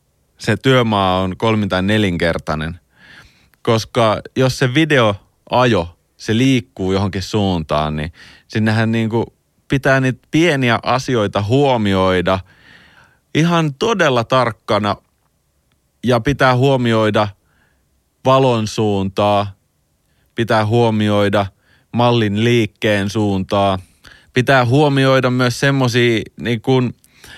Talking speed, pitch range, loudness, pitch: 95 wpm, 95-125 Hz, -16 LUFS, 110 Hz